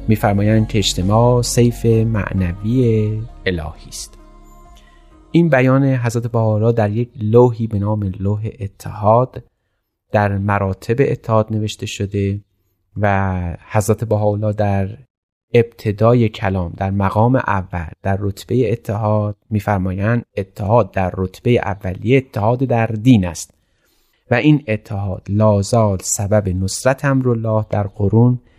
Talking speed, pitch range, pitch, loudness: 110 wpm, 100-120 Hz, 105 Hz, -17 LUFS